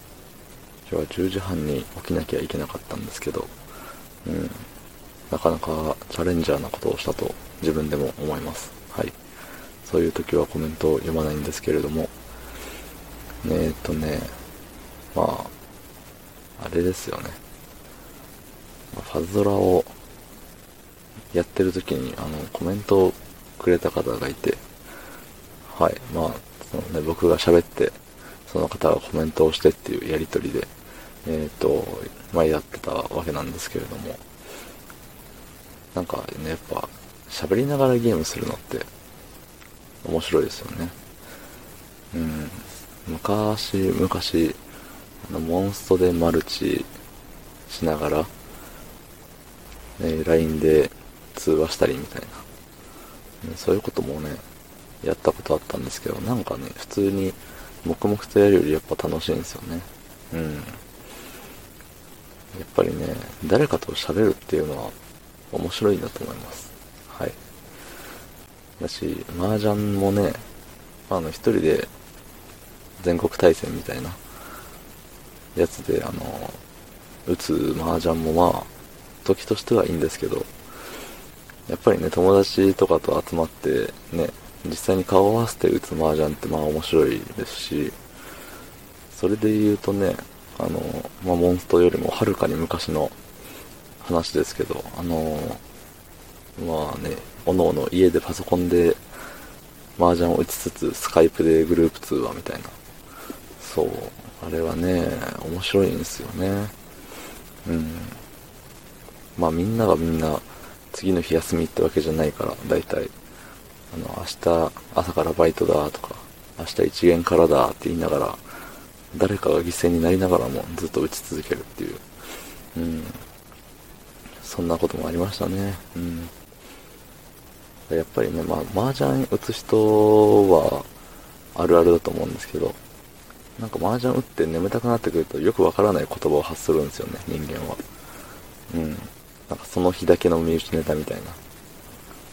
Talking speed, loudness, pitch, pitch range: 270 characters per minute, -23 LUFS, 85 Hz, 80-95 Hz